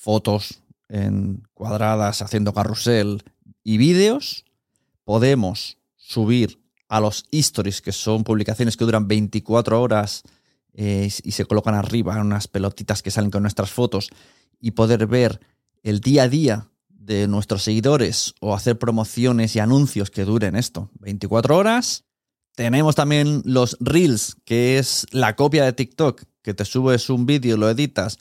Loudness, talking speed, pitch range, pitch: -20 LUFS, 145 wpm, 105-125 Hz, 110 Hz